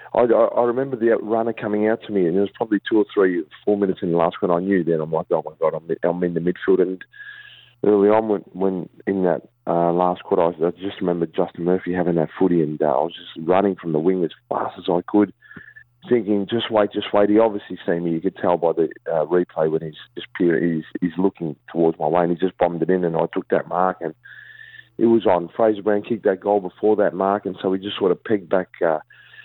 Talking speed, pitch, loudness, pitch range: 265 wpm, 95 Hz, -21 LUFS, 85-105 Hz